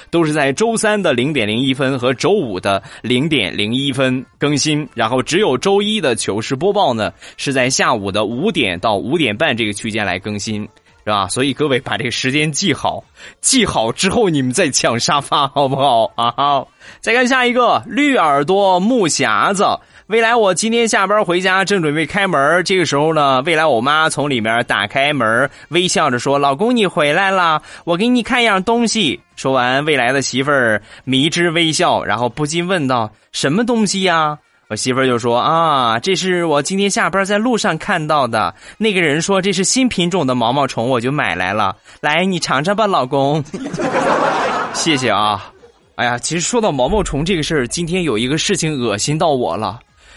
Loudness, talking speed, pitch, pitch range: -15 LUFS, 280 characters per minute, 155 Hz, 130-195 Hz